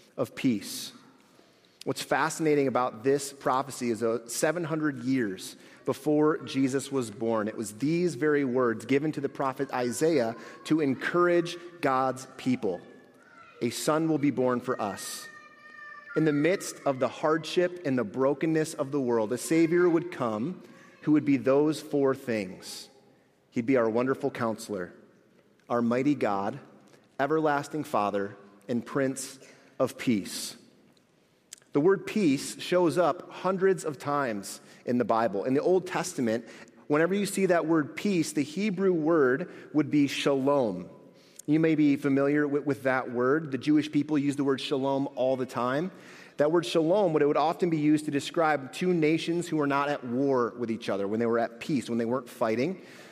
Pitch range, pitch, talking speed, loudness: 125-155 Hz, 140 Hz, 165 wpm, -28 LUFS